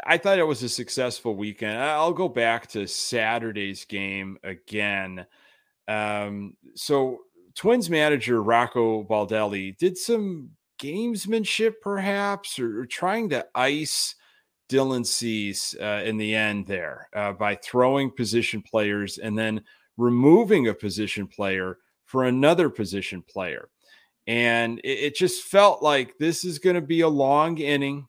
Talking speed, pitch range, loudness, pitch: 140 wpm, 105-155 Hz, -24 LUFS, 120 Hz